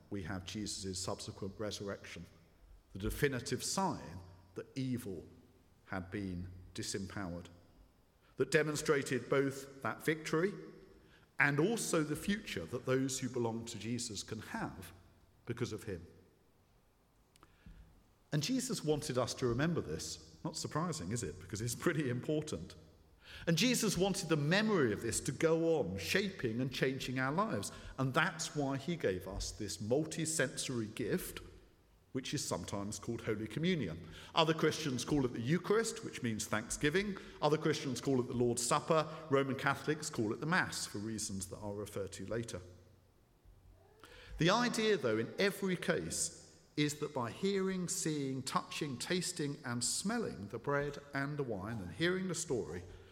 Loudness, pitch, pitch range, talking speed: -37 LUFS, 120 Hz, 95-155 Hz, 150 wpm